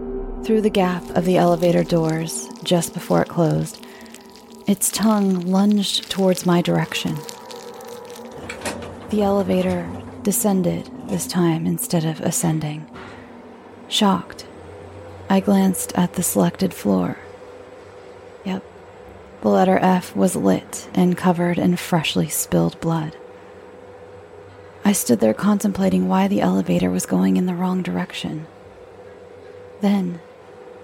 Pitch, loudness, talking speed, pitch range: 185 Hz, -20 LUFS, 115 wpm, 165-210 Hz